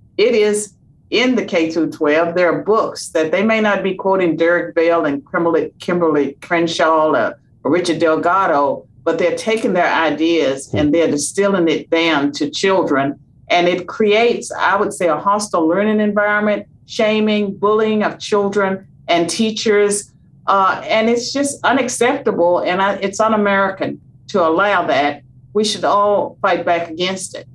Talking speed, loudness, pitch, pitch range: 155 wpm, -16 LUFS, 185 Hz, 165-210 Hz